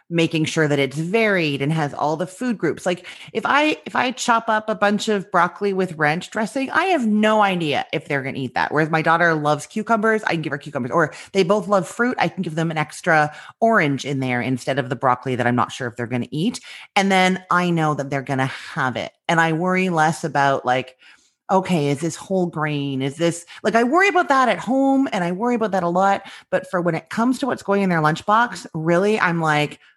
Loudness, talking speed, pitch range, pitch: -20 LUFS, 245 wpm, 150-210 Hz, 170 Hz